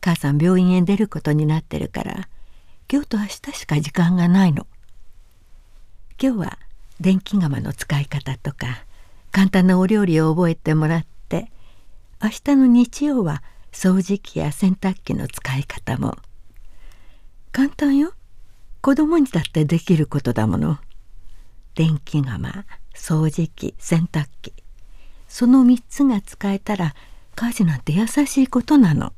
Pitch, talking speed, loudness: 160 Hz, 245 characters per minute, -20 LUFS